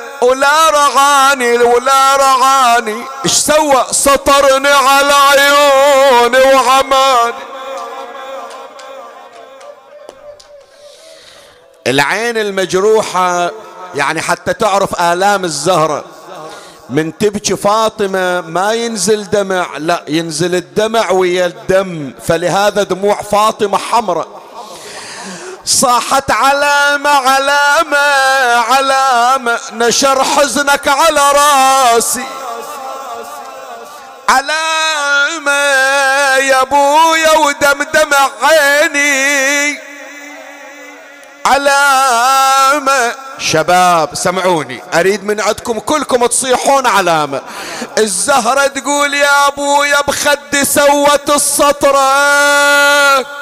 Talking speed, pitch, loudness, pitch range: 70 wpm, 270 Hz, -10 LUFS, 210-285 Hz